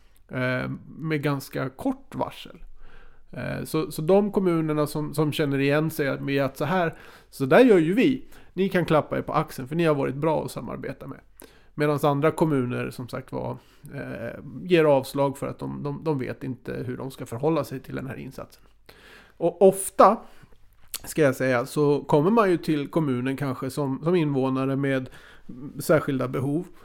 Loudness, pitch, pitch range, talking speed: -24 LUFS, 145 Hz, 130-160 Hz, 165 wpm